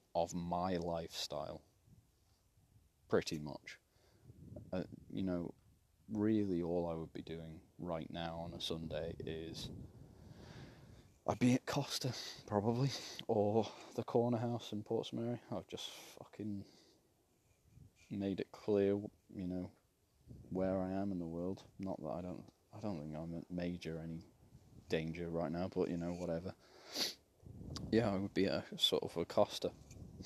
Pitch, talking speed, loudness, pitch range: 95 Hz, 145 wpm, -40 LUFS, 85-110 Hz